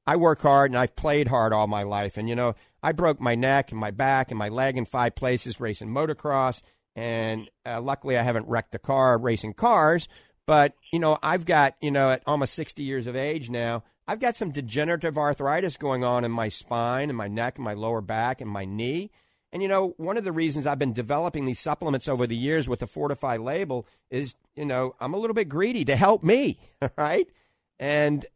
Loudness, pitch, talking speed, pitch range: -25 LUFS, 130 Hz, 220 wpm, 115-150 Hz